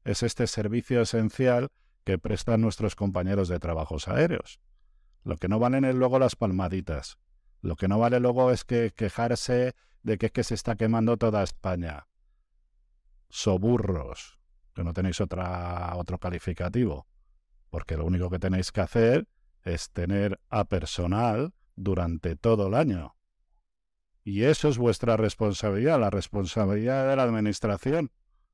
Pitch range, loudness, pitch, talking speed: 90-115 Hz, -27 LUFS, 100 Hz, 145 wpm